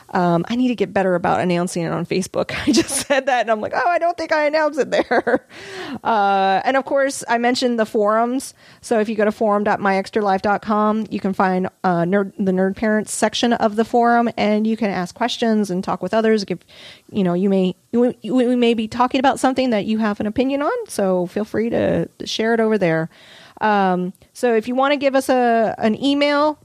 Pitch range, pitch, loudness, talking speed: 195-255 Hz, 220 Hz, -19 LUFS, 220 wpm